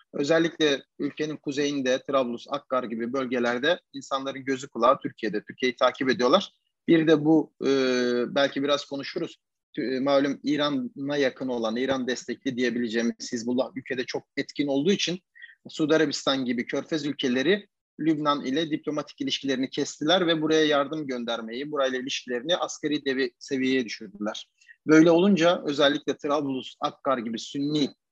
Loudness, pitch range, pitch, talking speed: -26 LUFS, 125-150 Hz, 140 Hz, 130 wpm